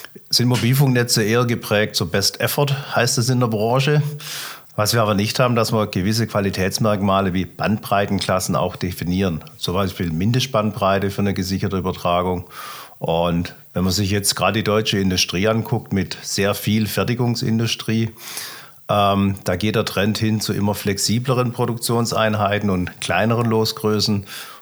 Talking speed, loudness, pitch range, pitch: 145 wpm, -19 LUFS, 100-115 Hz, 105 Hz